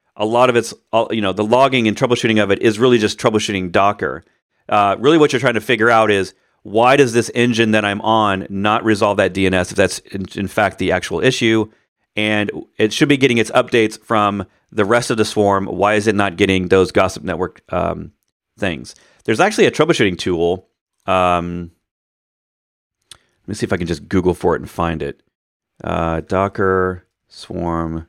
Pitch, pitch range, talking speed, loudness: 105 Hz, 95-115 Hz, 190 wpm, -16 LUFS